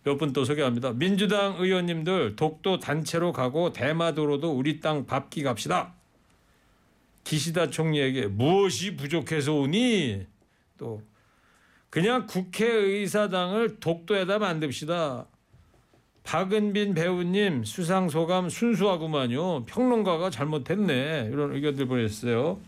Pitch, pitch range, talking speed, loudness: 165 Hz, 140-195 Hz, 265 characters per minute, -26 LUFS